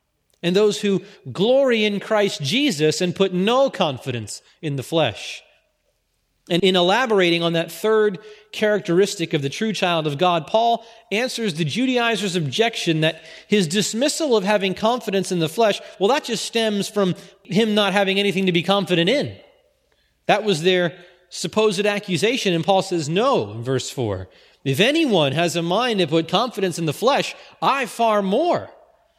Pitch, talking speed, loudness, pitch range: 195 Hz, 165 wpm, -20 LUFS, 170-215 Hz